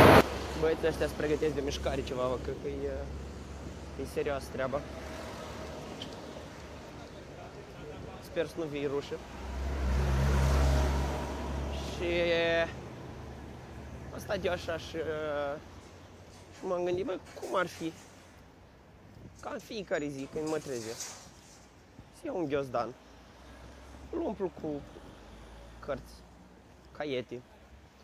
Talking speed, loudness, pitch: 95 wpm, -34 LUFS, 90 Hz